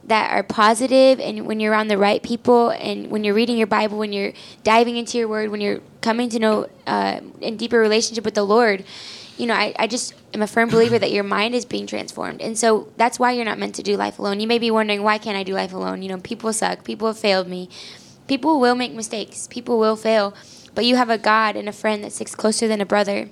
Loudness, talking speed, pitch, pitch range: -20 LUFS, 255 wpm, 215 Hz, 205-230 Hz